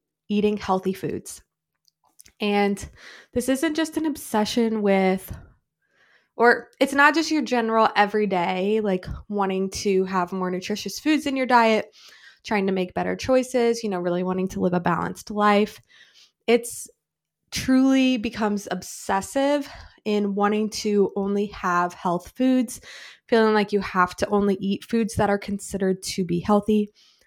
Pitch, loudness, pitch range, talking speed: 210 Hz, -23 LUFS, 190-235 Hz, 145 wpm